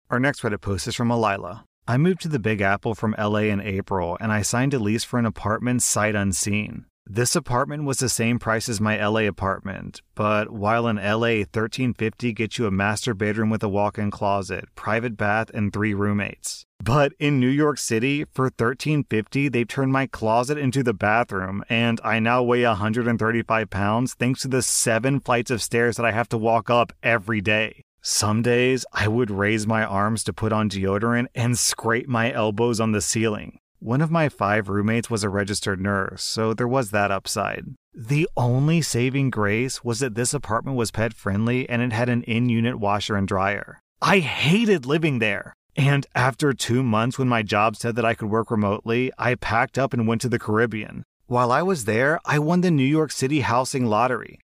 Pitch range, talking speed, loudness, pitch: 105-125 Hz, 200 wpm, -22 LUFS, 115 Hz